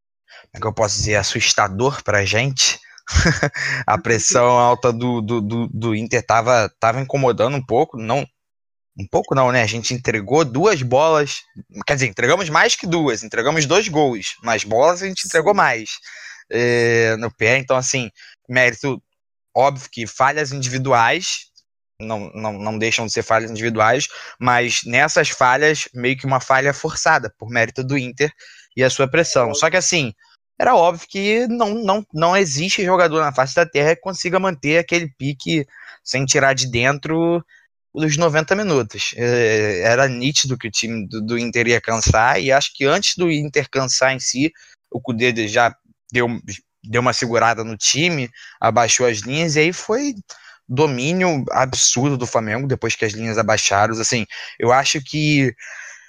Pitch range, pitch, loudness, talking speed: 115-150 Hz, 130 Hz, -17 LUFS, 165 wpm